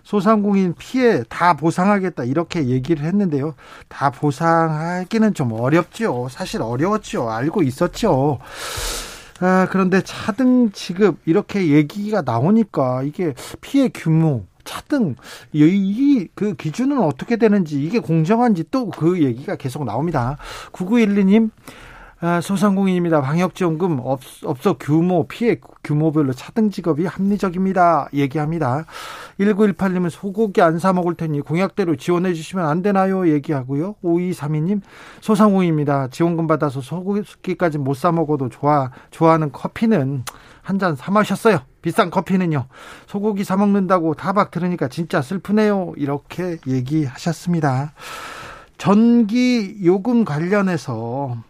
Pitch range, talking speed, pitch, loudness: 150-200 Hz, 290 characters per minute, 175 Hz, -19 LUFS